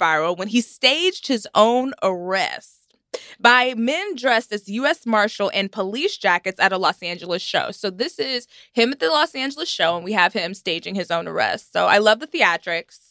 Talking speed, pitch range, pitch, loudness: 190 wpm, 190-260 Hz, 215 Hz, -20 LUFS